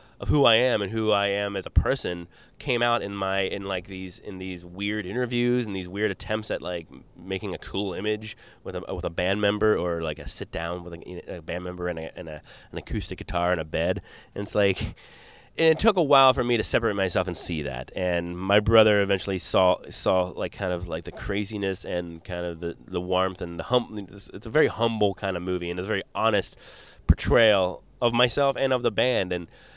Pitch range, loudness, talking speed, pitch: 90-110 Hz, -25 LUFS, 230 wpm, 95 Hz